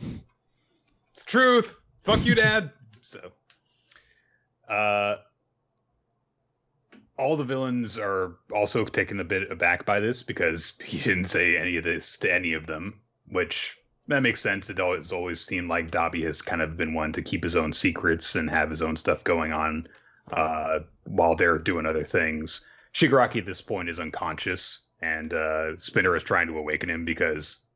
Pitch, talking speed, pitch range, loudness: 90 Hz, 170 wpm, 80-120 Hz, -25 LUFS